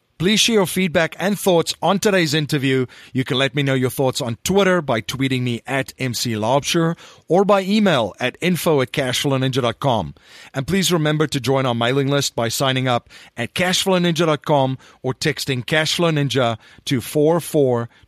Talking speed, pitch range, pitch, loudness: 160 wpm, 130-170 Hz, 140 Hz, -19 LUFS